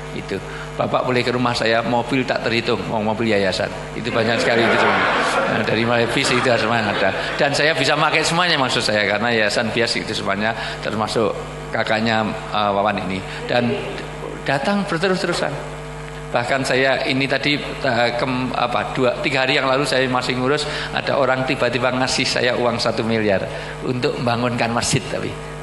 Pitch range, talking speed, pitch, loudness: 115-140 Hz, 170 wpm, 125 Hz, -19 LUFS